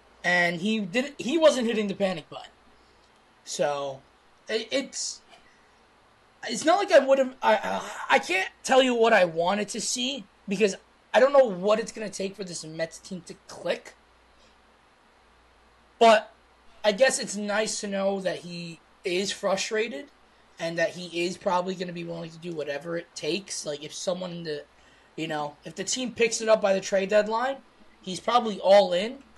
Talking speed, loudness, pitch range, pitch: 180 wpm, -26 LUFS, 175-230 Hz, 205 Hz